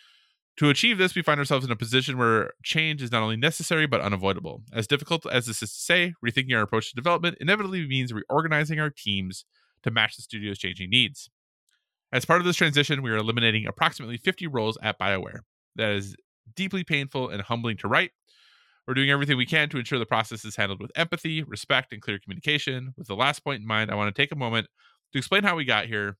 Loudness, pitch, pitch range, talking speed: -25 LUFS, 125 Hz, 110-150 Hz, 220 wpm